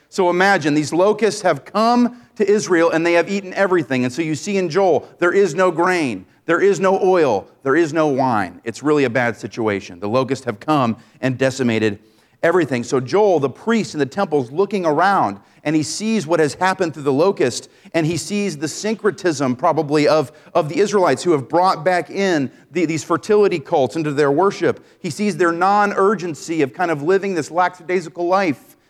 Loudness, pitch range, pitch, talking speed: -18 LUFS, 145-195 Hz, 170 Hz, 195 wpm